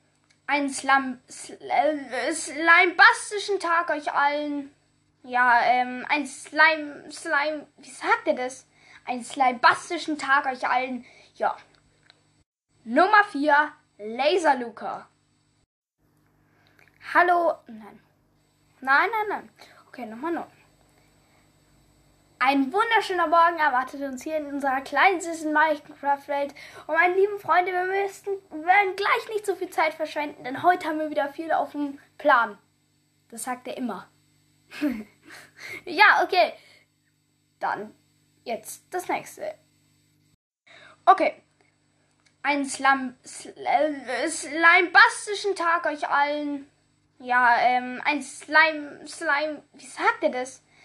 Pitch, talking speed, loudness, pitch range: 310 Hz, 115 wpm, -23 LUFS, 275-355 Hz